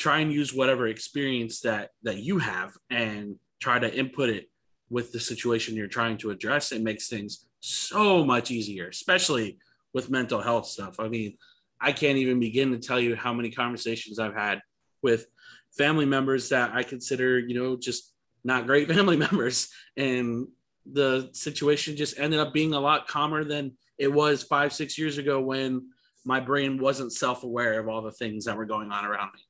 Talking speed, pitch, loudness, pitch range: 185 wpm, 130 Hz, -27 LUFS, 115-140 Hz